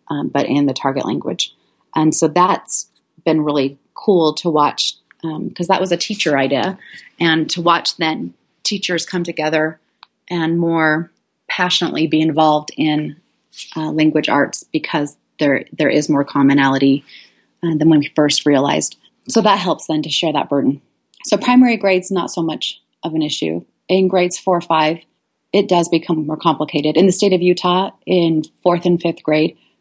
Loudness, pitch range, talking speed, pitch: -16 LUFS, 150-180 Hz, 175 wpm, 160 Hz